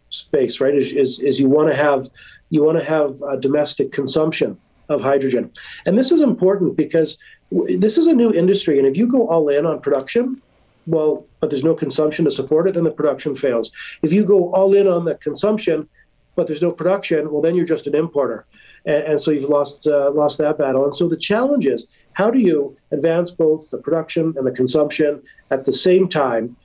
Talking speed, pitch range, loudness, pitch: 215 wpm, 145-175 Hz, -18 LUFS, 155 Hz